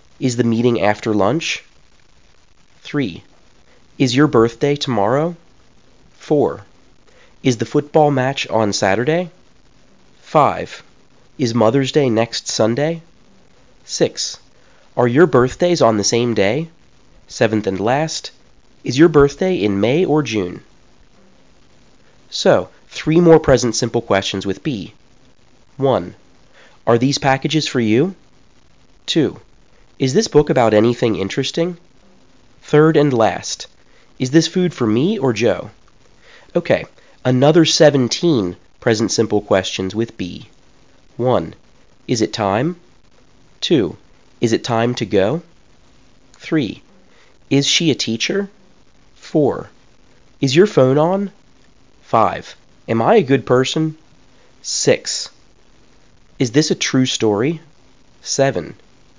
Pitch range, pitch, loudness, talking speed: 115-155 Hz, 130 Hz, -16 LUFS, 115 wpm